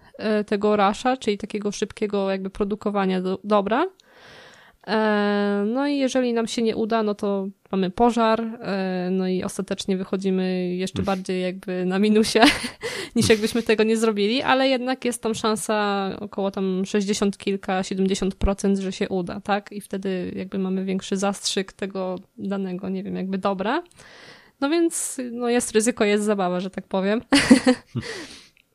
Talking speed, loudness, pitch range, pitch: 140 wpm, -23 LUFS, 195-225 Hz, 205 Hz